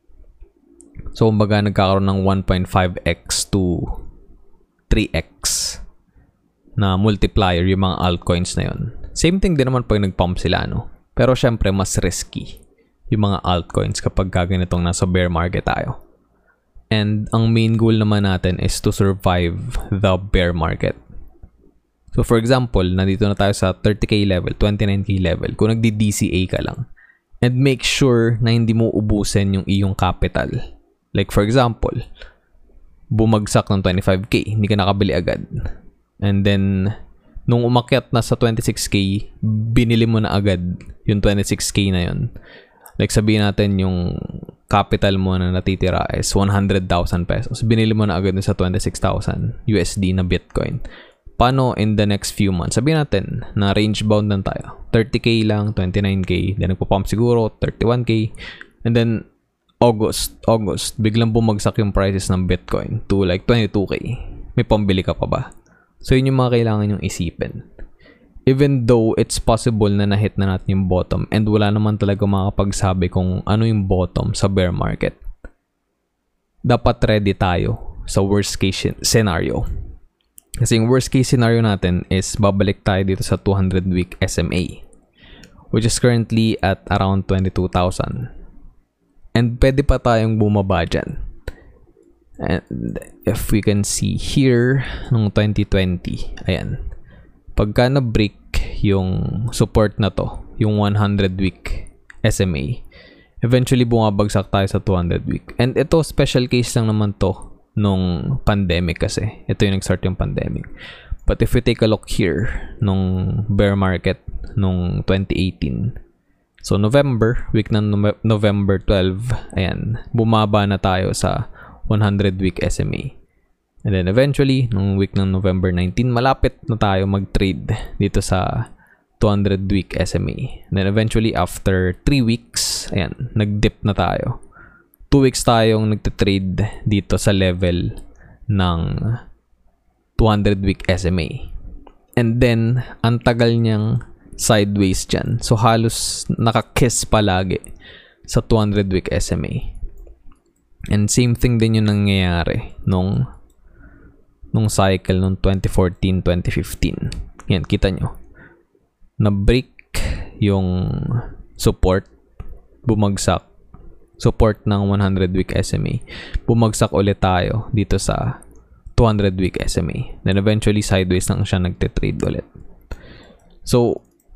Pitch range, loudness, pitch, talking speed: 95-115 Hz, -18 LUFS, 100 Hz, 125 wpm